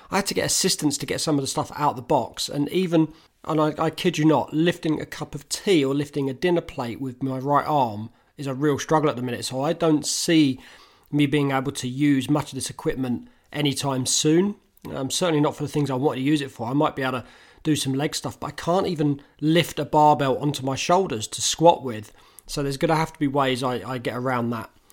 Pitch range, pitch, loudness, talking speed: 135-155 Hz, 145 Hz, -23 LUFS, 255 wpm